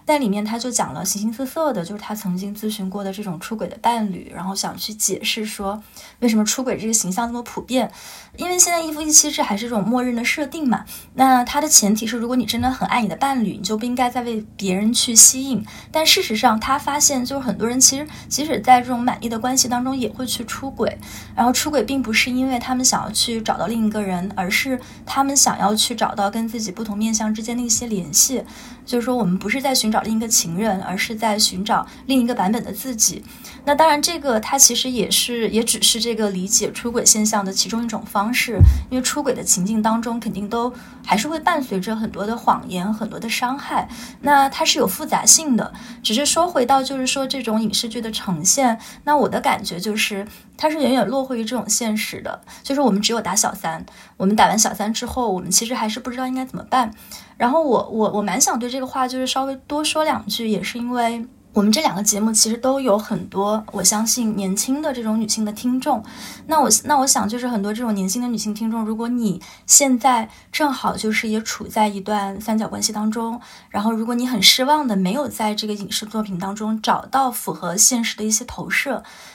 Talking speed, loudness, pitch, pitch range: 335 characters per minute, -18 LUFS, 230 Hz, 210-255 Hz